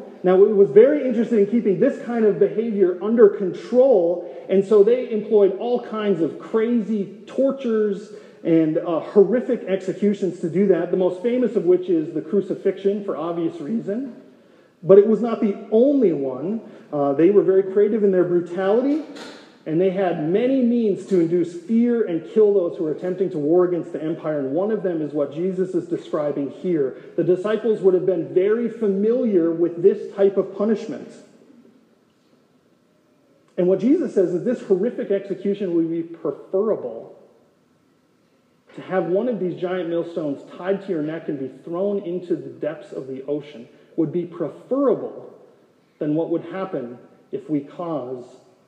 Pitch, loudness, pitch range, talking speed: 195 Hz, -21 LUFS, 175-225 Hz, 170 wpm